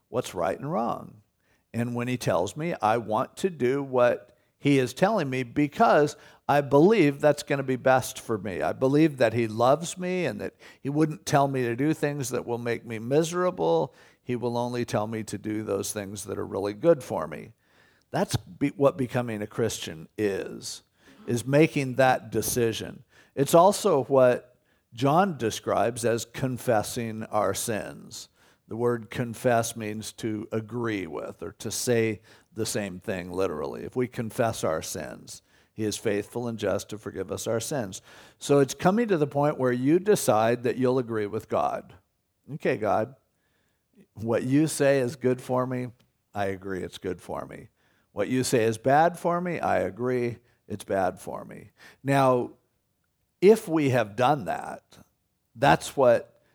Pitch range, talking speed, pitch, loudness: 110-140 Hz, 170 wpm, 125 Hz, -26 LUFS